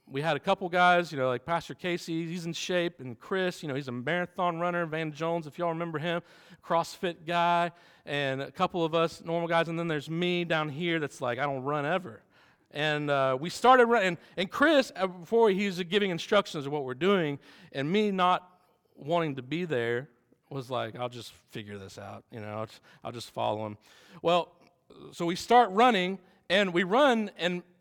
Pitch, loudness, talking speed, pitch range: 170 Hz, -28 LUFS, 205 wpm, 145-180 Hz